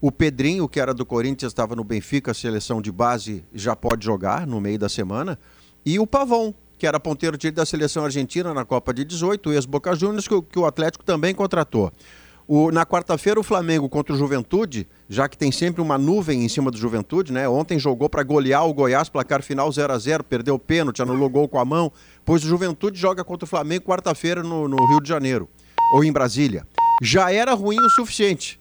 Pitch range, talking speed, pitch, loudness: 130-175 Hz, 210 wpm, 150 Hz, -21 LUFS